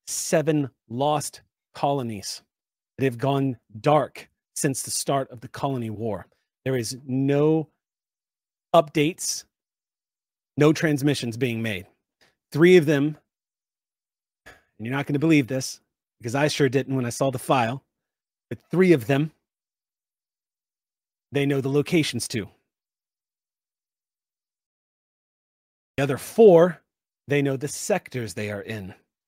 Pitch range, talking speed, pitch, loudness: 120-150 Hz, 125 wpm, 140 Hz, -23 LUFS